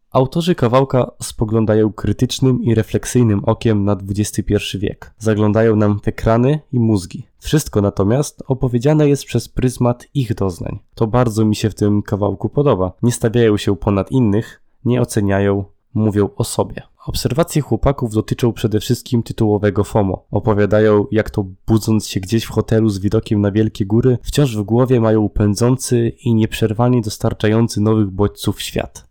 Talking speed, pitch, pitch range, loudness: 150 wpm, 110 Hz, 105-125 Hz, -17 LUFS